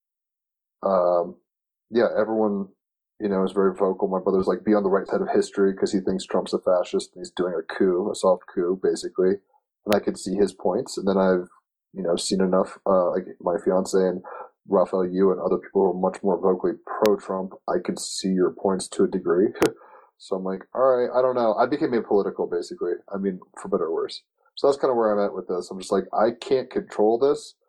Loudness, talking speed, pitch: -24 LUFS, 225 wpm, 120 Hz